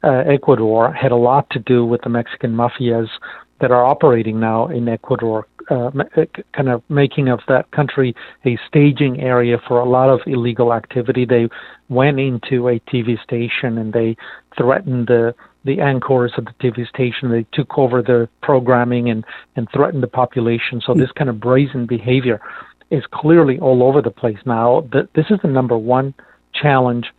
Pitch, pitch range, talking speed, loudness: 125 Hz, 120-135 Hz, 180 wpm, -16 LUFS